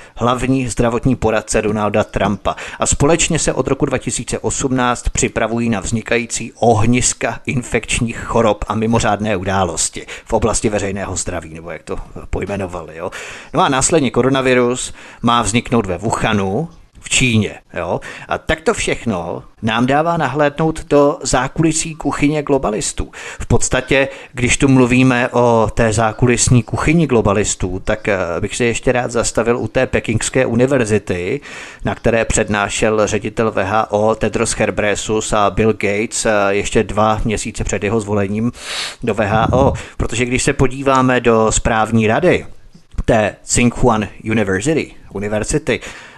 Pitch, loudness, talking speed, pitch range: 115 Hz, -16 LUFS, 130 wpm, 105-125 Hz